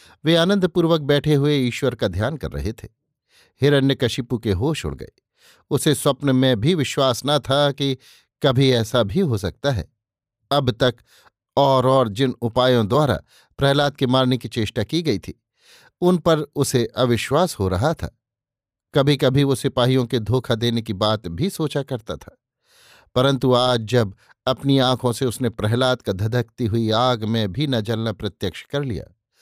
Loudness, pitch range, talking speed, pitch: -20 LUFS, 115-140 Hz, 170 wpm, 130 Hz